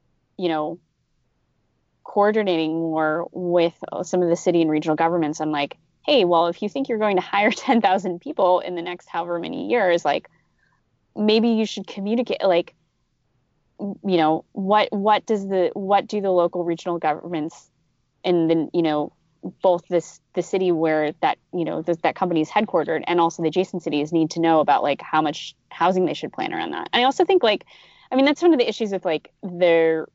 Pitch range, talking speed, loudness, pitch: 160-200 Hz, 195 wpm, -21 LUFS, 175 Hz